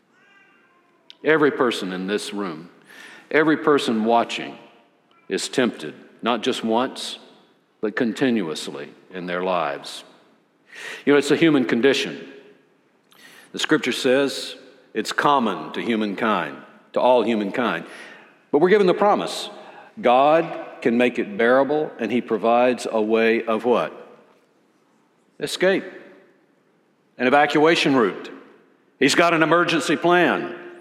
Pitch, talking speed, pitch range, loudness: 125 Hz, 115 wpm, 115-150 Hz, -20 LUFS